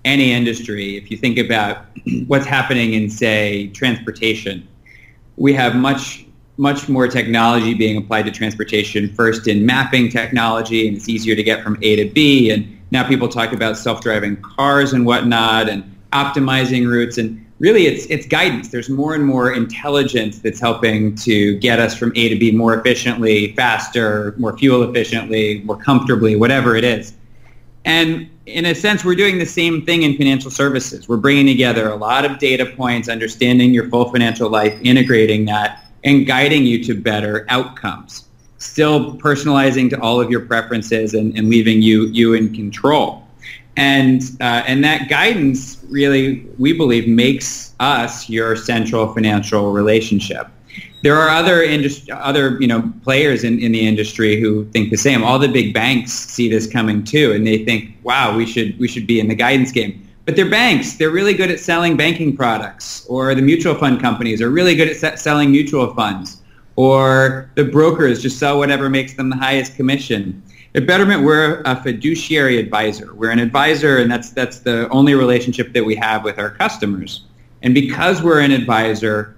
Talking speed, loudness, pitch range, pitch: 180 wpm, -15 LUFS, 110-135 Hz, 120 Hz